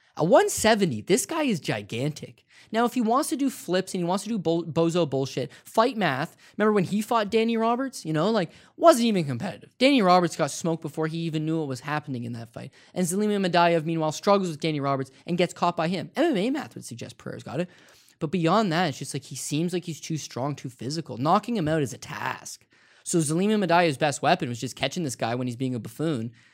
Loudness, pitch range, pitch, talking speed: -25 LUFS, 145-200 Hz, 165 Hz, 235 wpm